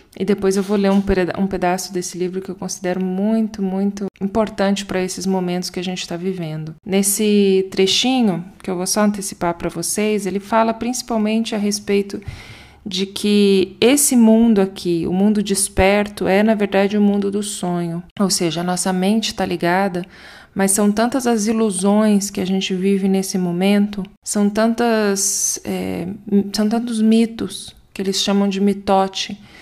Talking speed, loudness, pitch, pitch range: 165 wpm, -18 LUFS, 195 Hz, 185-210 Hz